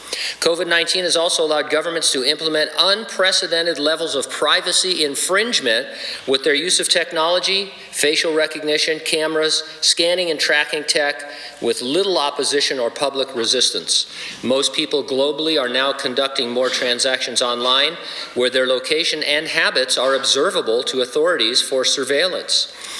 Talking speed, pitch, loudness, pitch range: 135 wpm, 155 Hz, -17 LUFS, 140-175 Hz